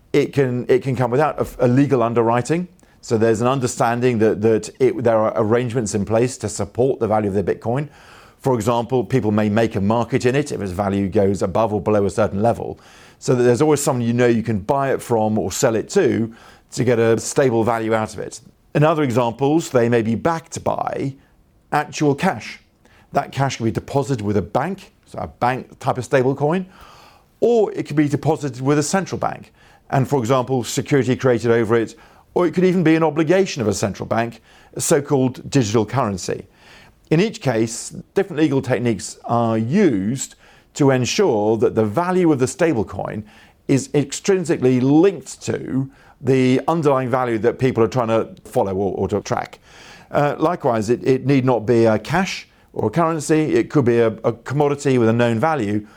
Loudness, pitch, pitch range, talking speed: -19 LUFS, 125 Hz, 115-145 Hz, 195 wpm